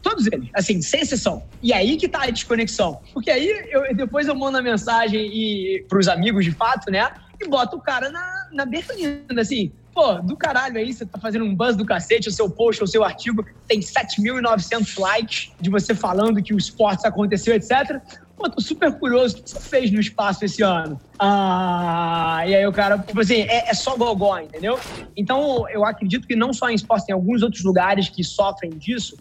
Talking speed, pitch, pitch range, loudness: 205 wpm, 220 Hz, 200-250 Hz, -20 LUFS